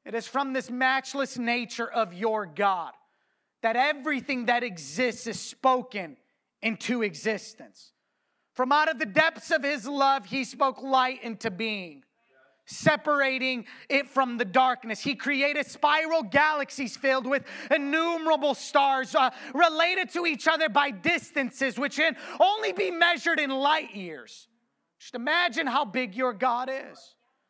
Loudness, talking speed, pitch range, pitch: -26 LUFS, 140 wpm, 240-300 Hz, 270 Hz